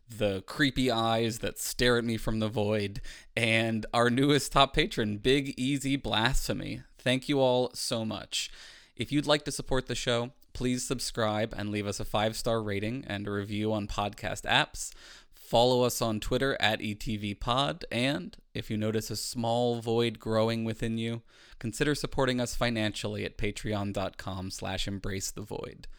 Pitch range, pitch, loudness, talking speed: 105-125 Hz, 115 Hz, -30 LUFS, 165 wpm